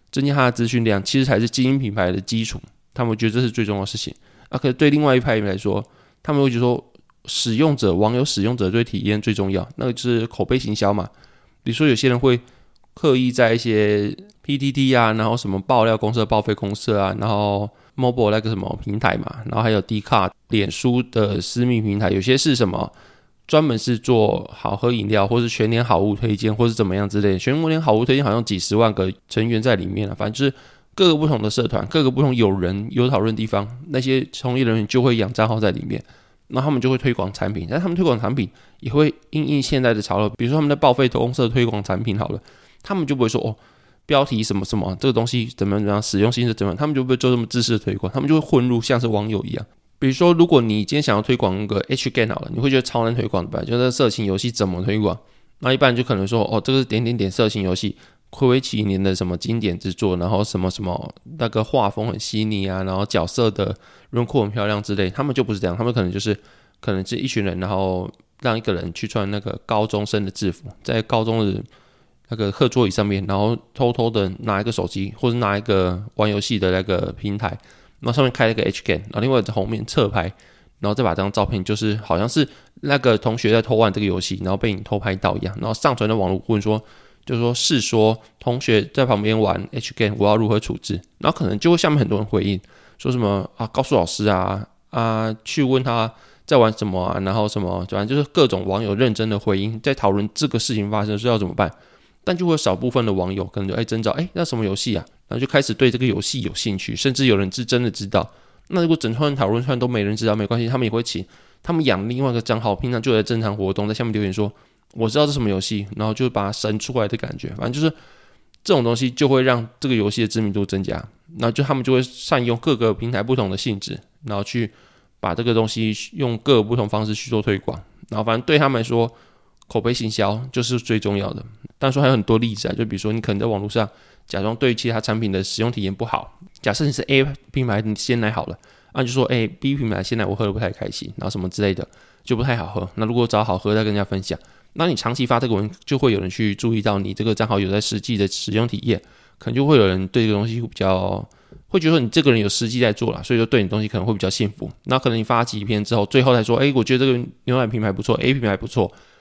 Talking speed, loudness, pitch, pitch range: 375 characters per minute, -20 LUFS, 110 Hz, 100-125 Hz